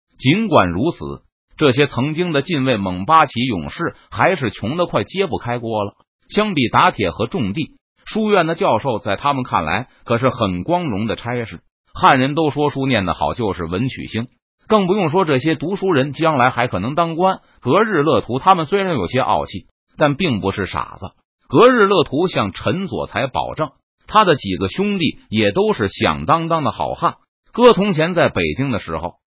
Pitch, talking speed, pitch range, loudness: 135 Hz, 270 characters per minute, 110-170 Hz, -17 LUFS